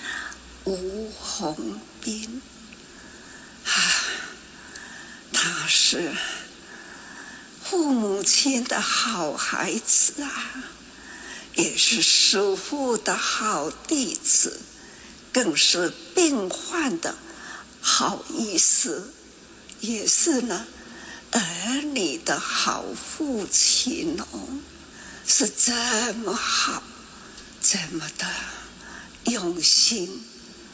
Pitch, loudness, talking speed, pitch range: 250 Hz, -21 LUFS, 95 characters per minute, 215-295 Hz